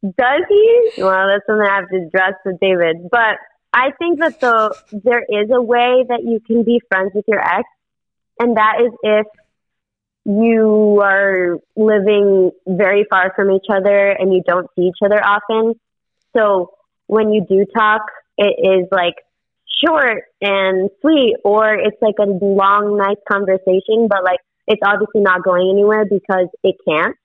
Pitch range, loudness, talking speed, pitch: 190-220 Hz, -14 LUFS, 165 wpm, 205 Hz